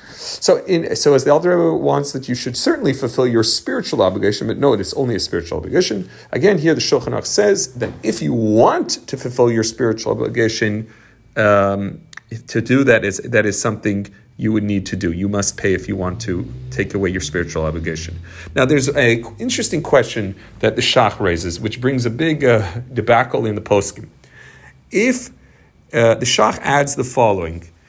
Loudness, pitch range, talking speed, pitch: -17 LUFS, 100-130 Hz, 185 wpm, 115 Hz